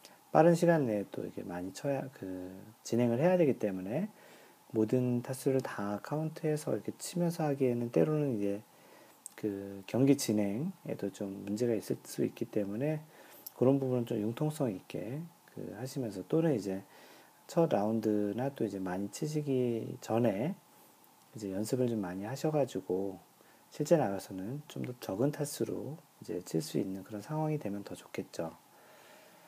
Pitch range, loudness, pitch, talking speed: 100-145 Hz, -34 LUFS, 115 Hz, 300 characters per minute